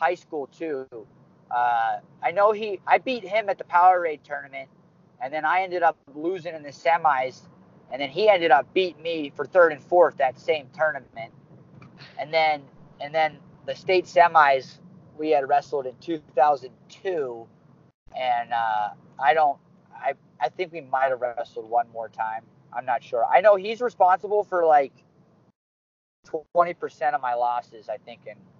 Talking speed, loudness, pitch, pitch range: 170 wpm, -23 LUFS, 155 Hz, 130-180 Hz